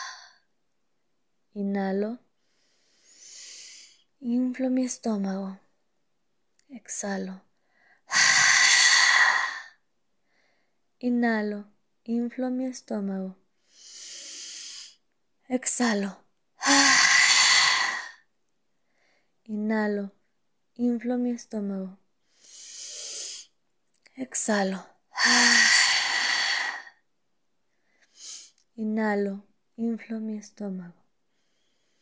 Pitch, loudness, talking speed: 235 Hz, -22 LUFS, 35 wpm